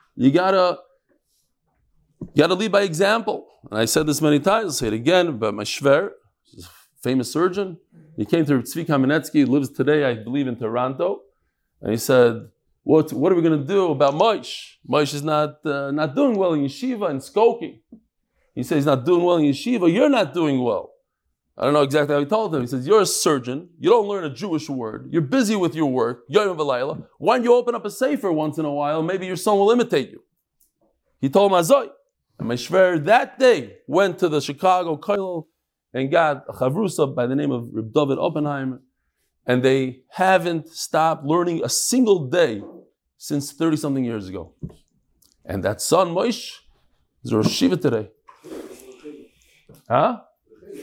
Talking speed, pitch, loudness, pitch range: 180 wpm, 155 Hz, -20 LUFS, 140-190 Hz